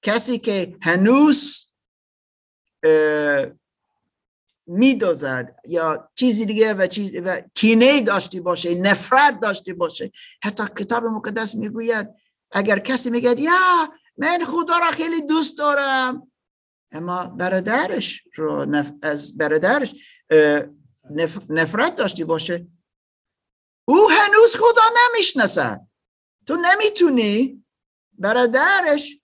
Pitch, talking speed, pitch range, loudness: 220 Hz, 95 wpm, 180-290 Hz, -18 LUFS